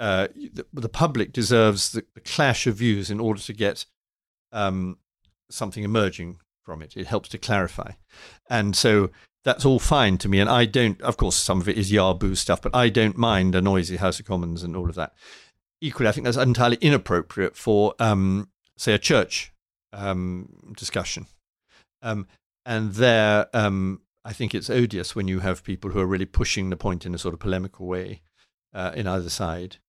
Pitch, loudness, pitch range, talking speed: 100 Hz, -23 LUFS, 95-115 Hz, 190 wpm